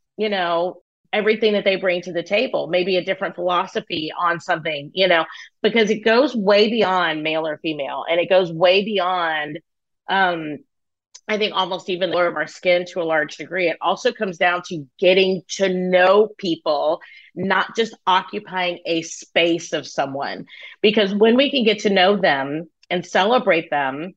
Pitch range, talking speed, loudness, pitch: 165-200 Hz, 175 wpm, -19 LUFS, 180 Hz